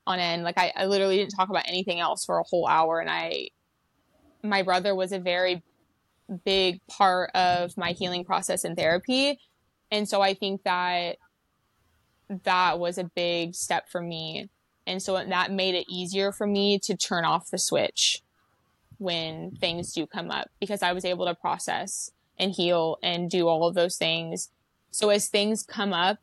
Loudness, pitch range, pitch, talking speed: -26 LUFS, 175-200 Hz, 185 Hz, 180 wpm